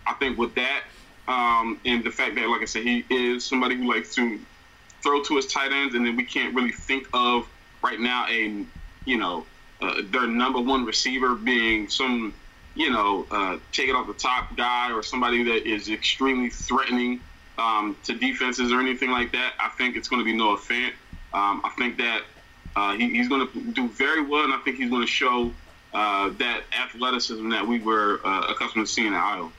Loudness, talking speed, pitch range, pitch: -24 LUFS, 210 wpm, 115-130 Hz, 125 Hz